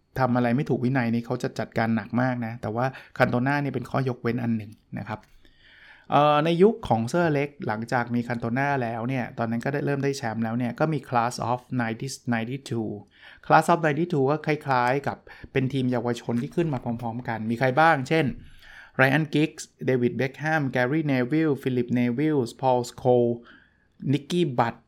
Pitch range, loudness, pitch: 120-140 Hz, -25 LUFS, 125 Hz